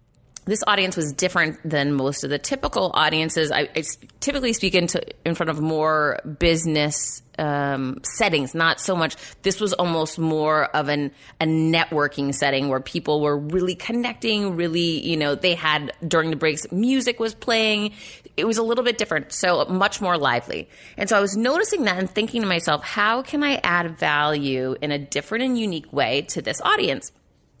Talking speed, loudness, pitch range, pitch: 185 wpm, -22 LUFS, 150-205 Hz, 165 Hz